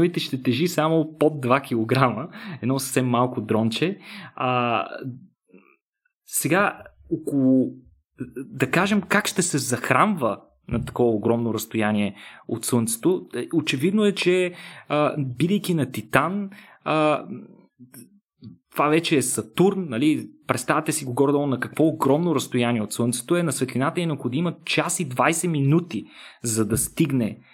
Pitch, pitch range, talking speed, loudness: 145 Hz, 120-170 Hz, 130 wpm, -23 LUFS